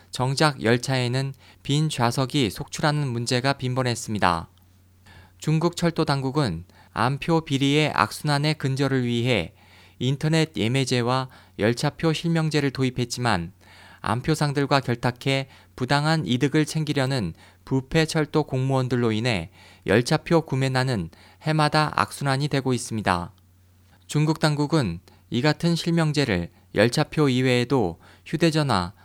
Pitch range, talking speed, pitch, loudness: 100-150 Hz, 280 characters per minute, 130 Hz, -24 LUFS